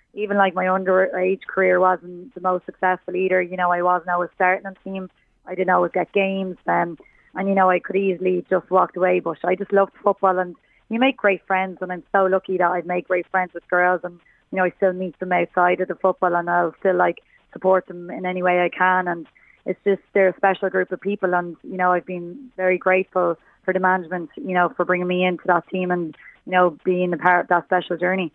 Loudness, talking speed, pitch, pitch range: -21 LUFS, 240 wpm, 185 Hz, 180-190 Hz